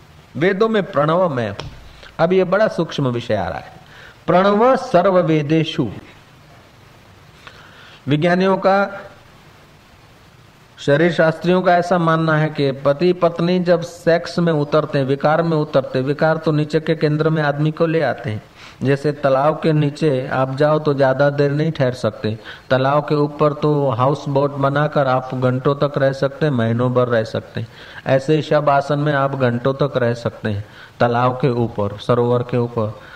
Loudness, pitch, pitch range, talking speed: -17 LUFS, 145 Hz, 125-160 Hz, 160 wpm